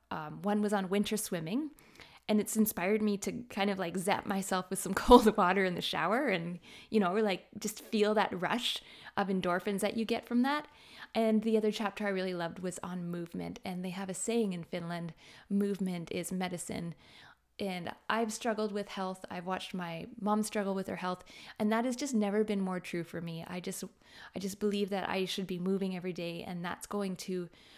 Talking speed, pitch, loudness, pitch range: 210 wpm, 195 Hz, -33 LUFS, 180-215 Hz